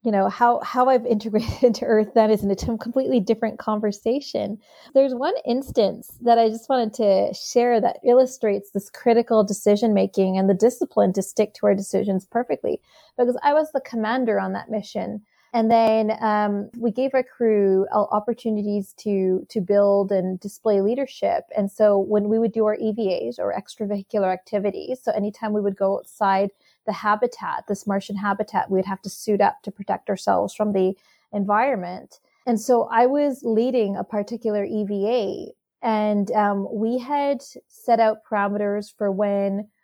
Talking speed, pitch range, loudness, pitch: 165 wpm, 200-235 Hz, -22 LUFS, 215 Hz